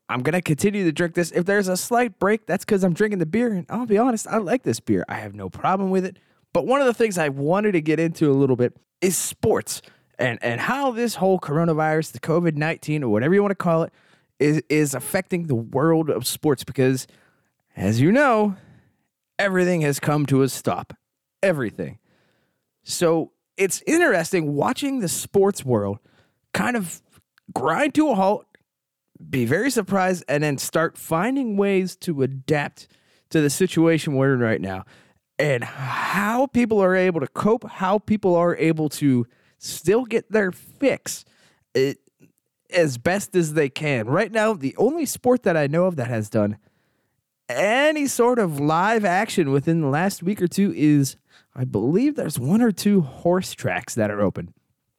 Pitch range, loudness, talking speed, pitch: 140-200 Hz, -22 LUFS, 185 wpm, 170 Hz